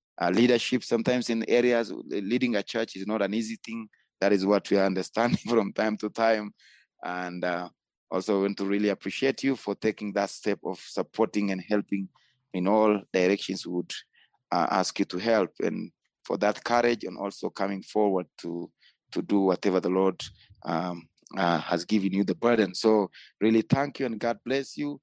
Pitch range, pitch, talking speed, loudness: 95-115 Hz, 105 Hz, 185 wpm, -27 LUFS